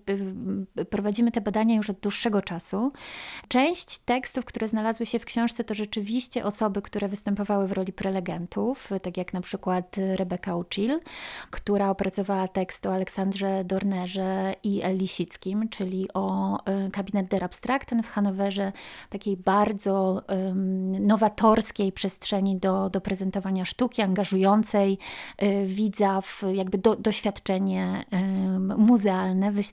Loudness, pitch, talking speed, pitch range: -26 LUFS, 200 Hz, 125 wpm, 190-215 Hz